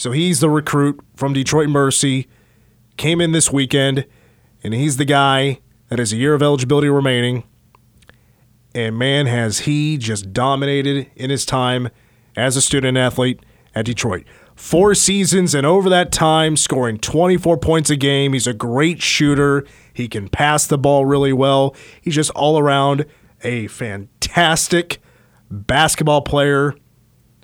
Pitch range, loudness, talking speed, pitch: 120-150 Hz, -16 LUFS, 145 wpm, 140 Hz